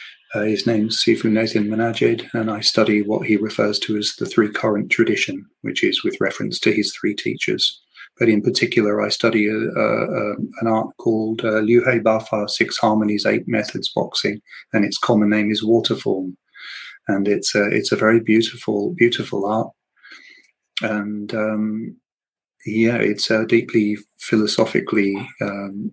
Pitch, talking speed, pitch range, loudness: 110 Hz, 155 wpm, 105-115 Hz, -19 LUFS